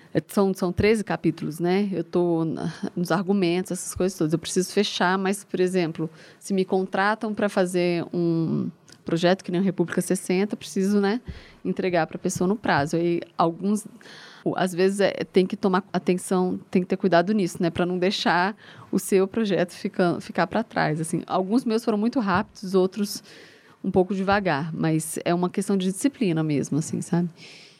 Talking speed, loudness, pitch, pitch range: 180 wpm, -24 LUFS, 185 Hz, 175-200 Hz